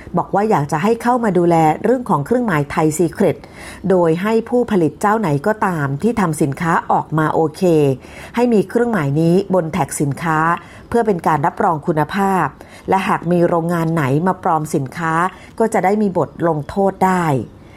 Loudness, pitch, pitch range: -17 LUFS, 175 Hz, 155-200 Hz